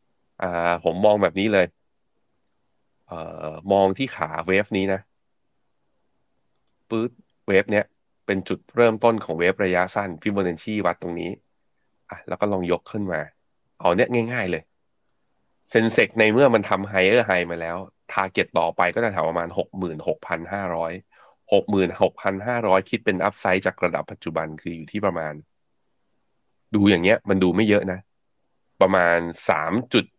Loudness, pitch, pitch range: -22 LUFS, 95 Hz, 85-105 Hz